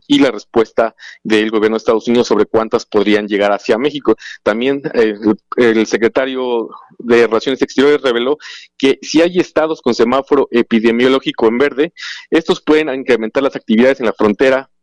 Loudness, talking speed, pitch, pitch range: -14 LUFS, 160 wpm, 125 Hz, 110-140 Hz